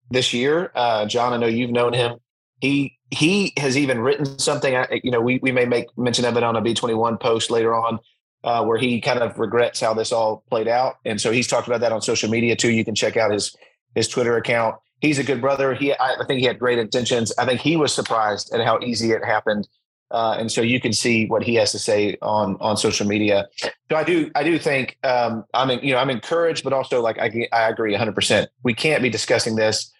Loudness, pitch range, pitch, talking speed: -20 LUFS, 115-125 Hz, 120 Hz, 250 wpm